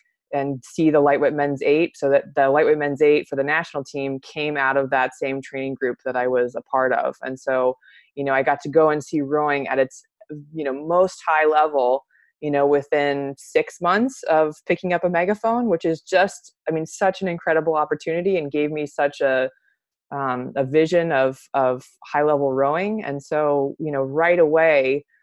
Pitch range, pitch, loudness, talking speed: 135-165 Hz, 150 Hz, -21 LUFS, 200 wpm